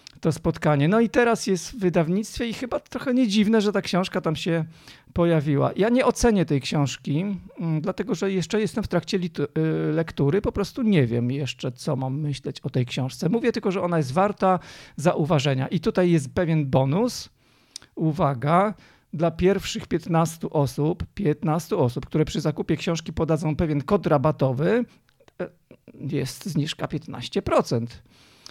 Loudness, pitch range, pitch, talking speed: -24 LUFS, 150-200 Hz, 170 Hz, 150 wpm